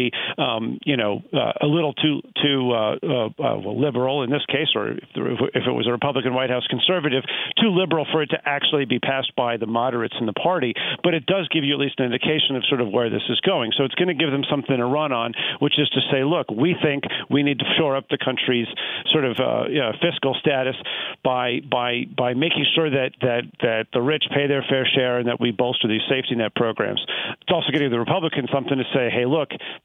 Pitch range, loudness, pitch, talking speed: 125-150 Hz, -21 LUFS, 135 Hz, 240 wpm